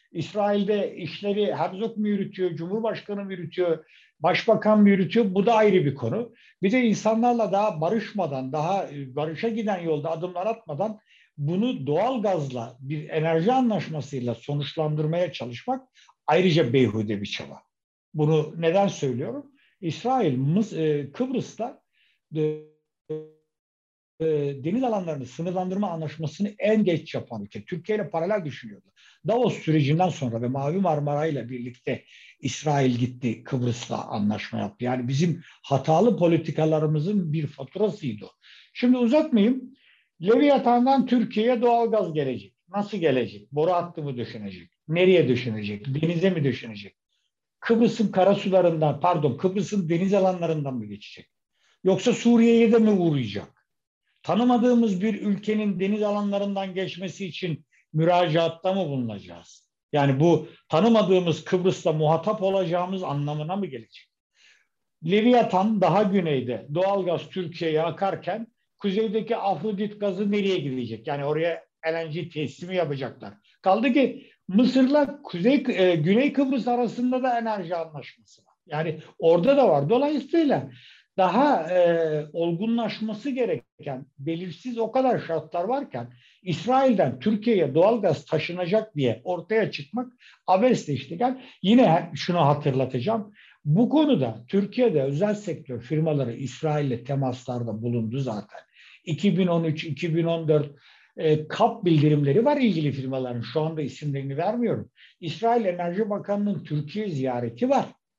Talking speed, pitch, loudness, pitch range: 115 wpm, 175 Hz, -24 LUFS, 145-215 Hz